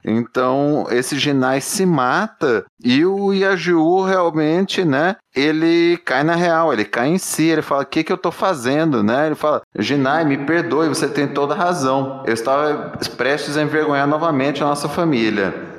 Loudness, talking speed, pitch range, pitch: -17 LUFS, 175 wpm, 140-175 Hz, 155 Hz